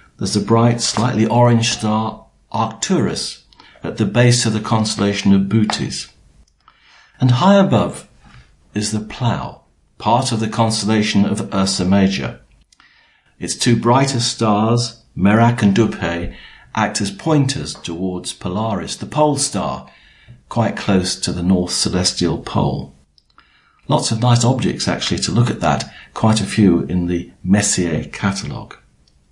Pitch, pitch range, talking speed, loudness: 105 Hz, 95-120 Hz, 135 wpm, -17 LUFS